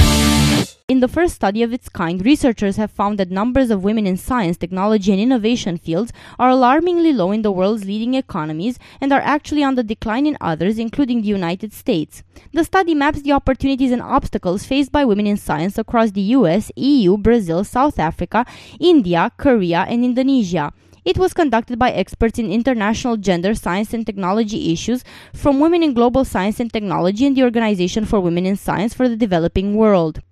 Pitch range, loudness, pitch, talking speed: 190-260 Hz, -17 LUFS, 225 Hz, 185 wpm